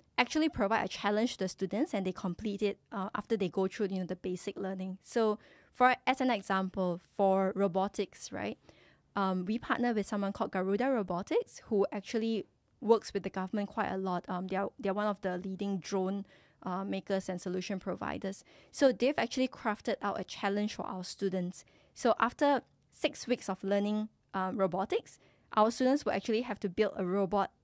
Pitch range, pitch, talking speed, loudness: 190-225 Hz, 200 Hz, 190 wpm, -33 LUFS